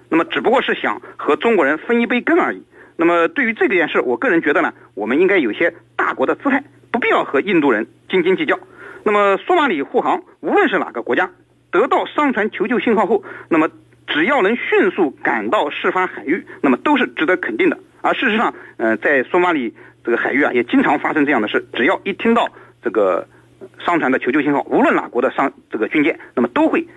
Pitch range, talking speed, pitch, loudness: 250-365 Hz, 330 characters per minute, 335 Hz, -17 LUFS